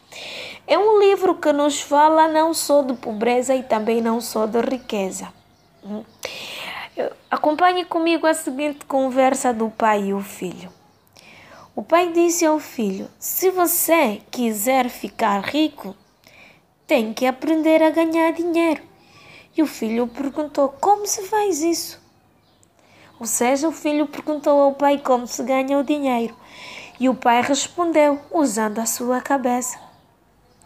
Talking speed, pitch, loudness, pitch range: 135 wpm, 285 Hz, -20 LUFS, 245-320 Hz